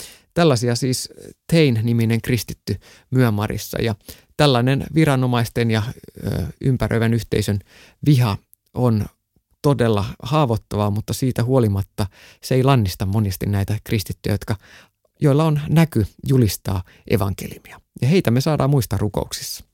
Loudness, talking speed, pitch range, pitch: -20 LUFS, 110 wpm, 105-130 Hz, 115 Hz